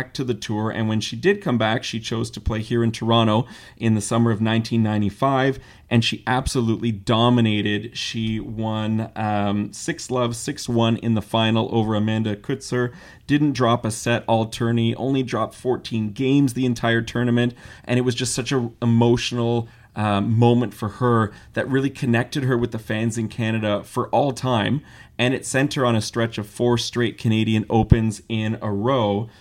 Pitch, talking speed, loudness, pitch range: 115 Hz, 180 wpm, -22 LUFS, 110-125 Hz